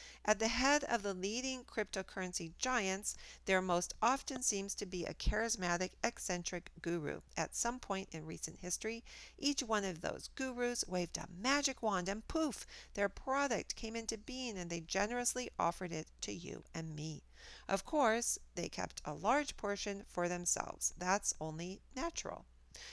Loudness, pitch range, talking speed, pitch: -38 LUFS, 180-245 Hz, 160 wpm, 200 Hz